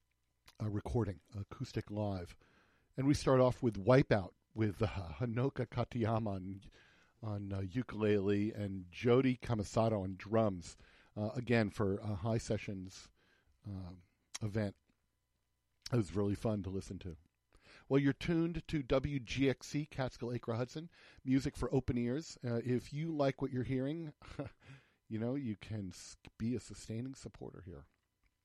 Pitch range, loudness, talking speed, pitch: 100-130 Hz, -37 LUFS, 140 wpm, 110 Hz